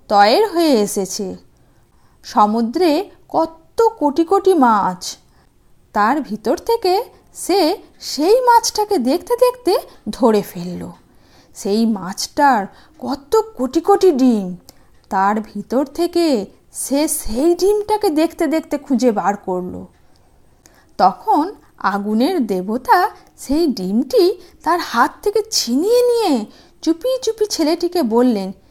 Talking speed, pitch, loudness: 100 wpm, 305 Hz, -17 LUFS